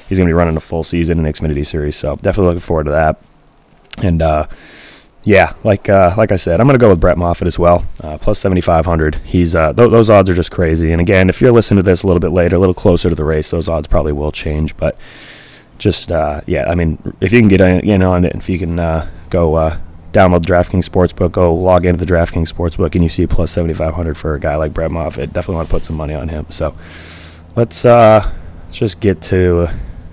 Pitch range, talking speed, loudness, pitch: 80-95 Hz, 245 wpm, -13 LUFS, 85 Hz